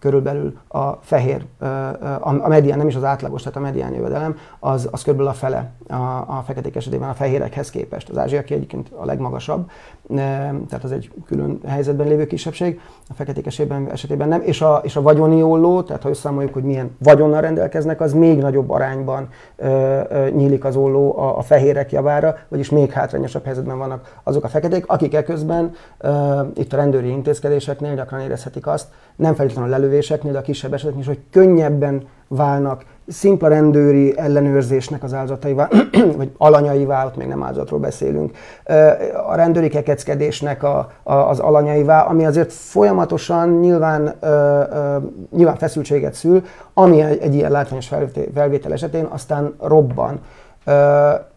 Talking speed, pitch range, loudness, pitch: 160 wpm, 135-155 Hz, -17 LUFS, 145 Hz